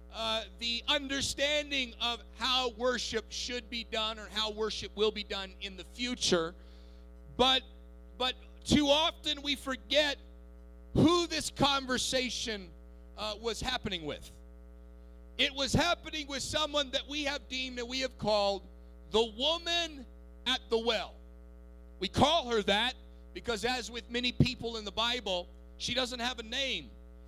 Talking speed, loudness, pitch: 145 wpm, -32 LUFS, 225 Hz